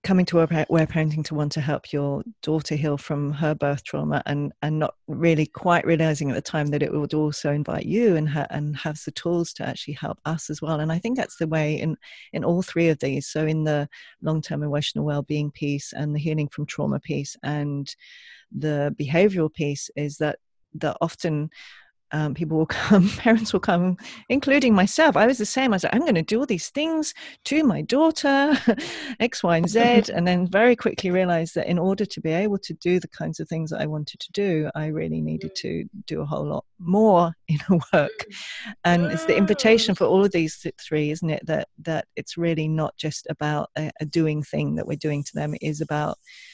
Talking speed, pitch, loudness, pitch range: 220 wpm, 160 Hz, -23 LUFS, 150-190 Hz